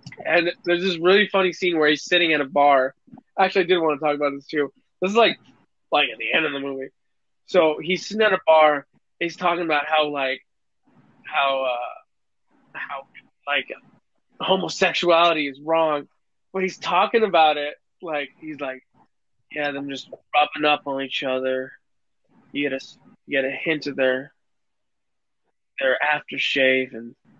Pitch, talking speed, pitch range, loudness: 150 Hz, 170 wpm, 140-175 Hz, -21 LUFS